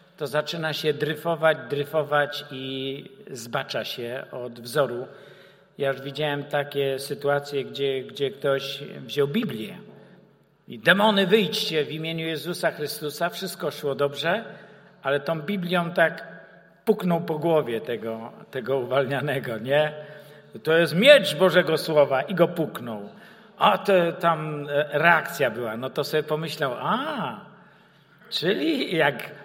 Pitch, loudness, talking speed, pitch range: 150 Hz, -24 LUFS, 125 wpm, 140-170 Hz